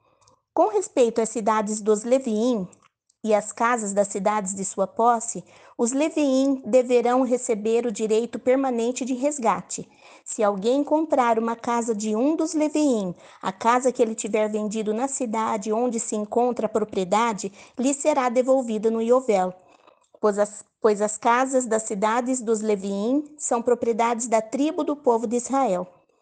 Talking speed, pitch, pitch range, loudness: 155 wpm, 235 Hz, 215-255 Hz, -23 LUFS